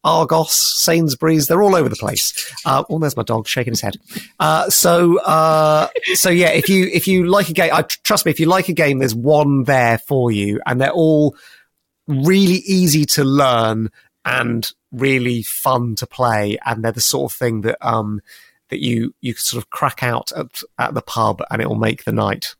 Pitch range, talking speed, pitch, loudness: 115-165 Hz, 200 wpm, 140 Hz, -16 LUFS